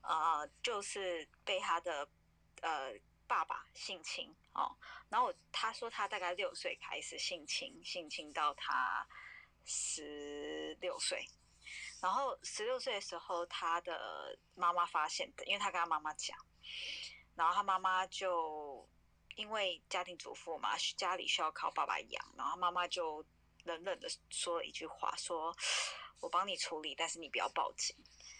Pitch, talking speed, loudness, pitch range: 175 Hz, 220 characters per minute, -39 LUFS, 155-220 Hz